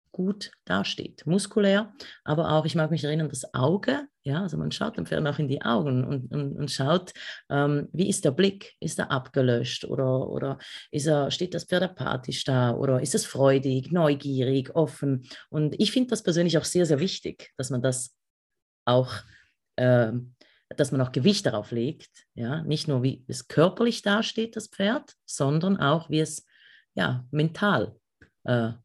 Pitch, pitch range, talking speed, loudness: 150 Hz, 130-180 Hz, 175 wpm, -26 LUFS